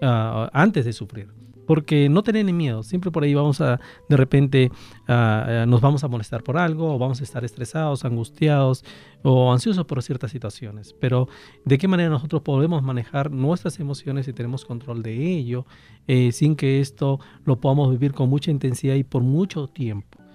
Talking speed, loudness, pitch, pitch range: 185 wpm, -21 LUFS, 135 Hz, 125-150 Hz